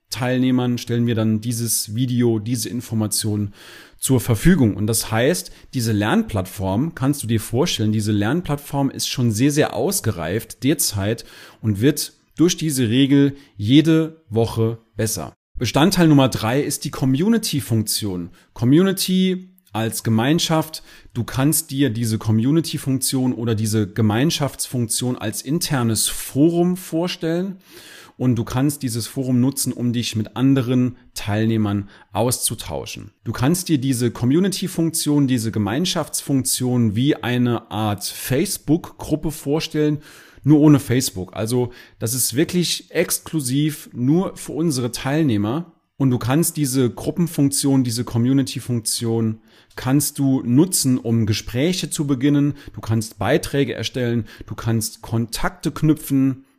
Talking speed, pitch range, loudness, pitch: 120 wpm, 110-150 Hz, -20 LUFS, 125 Hz